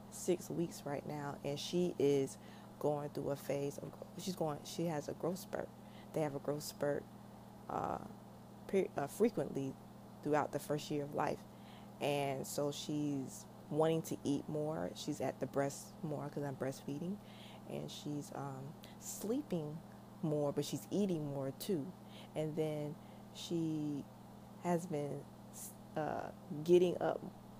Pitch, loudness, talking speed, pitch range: 145 Hz, -40 LUFS, 145 wpm, 140-160 Hz